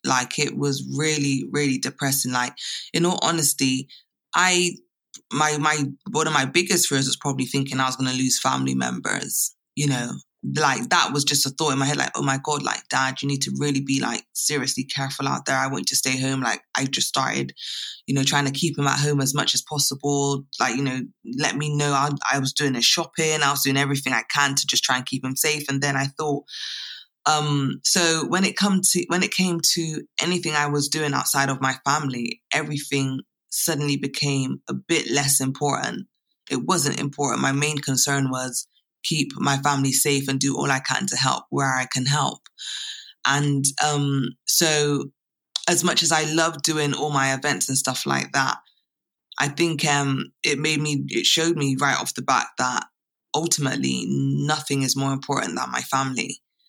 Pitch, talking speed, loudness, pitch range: 140 Hz, 200 wpm, -22 LUFS, 135-150 Hz